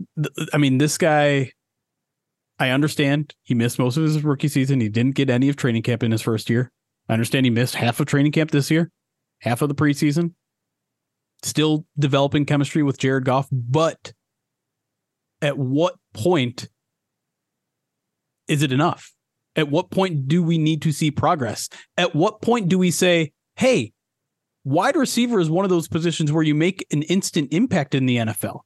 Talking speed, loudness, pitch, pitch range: 175 wpm, -21 LUFS, 150 Hz, 130-165 Hz